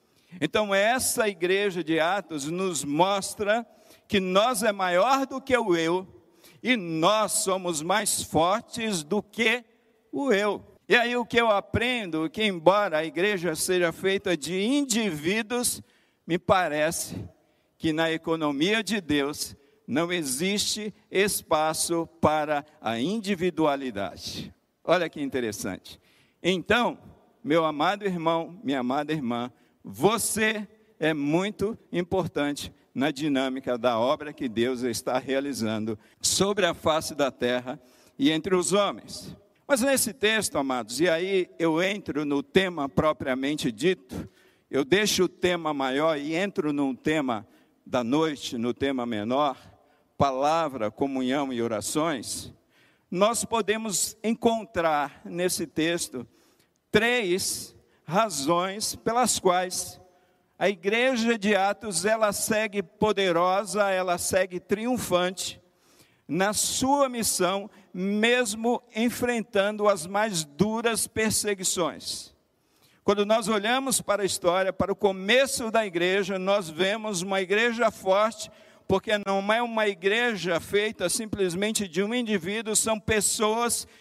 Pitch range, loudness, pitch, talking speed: 160-215 Hz, -26 LUFS, 190 Hz, 120 wpm